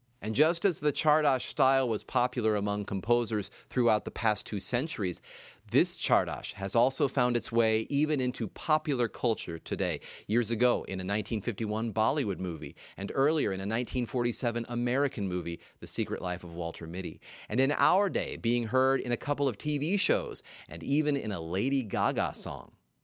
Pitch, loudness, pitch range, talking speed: 120 Hz, -30 LUFS, 105-135 Hz, 170 wpm